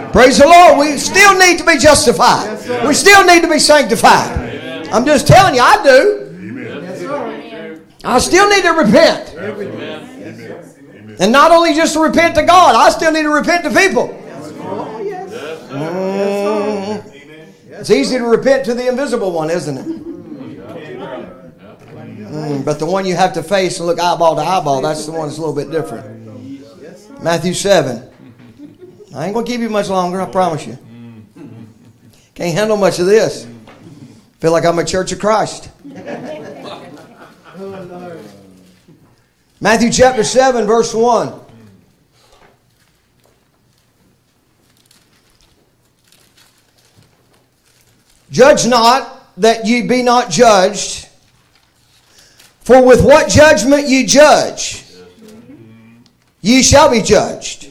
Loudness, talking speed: -11 LUFS, 125 wpm